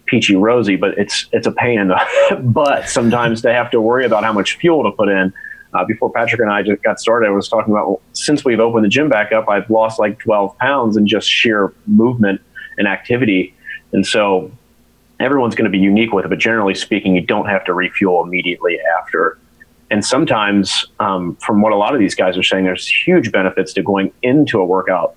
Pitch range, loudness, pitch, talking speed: 95-115 Hz, -14 LUFS, 105 Hz, 220 wpm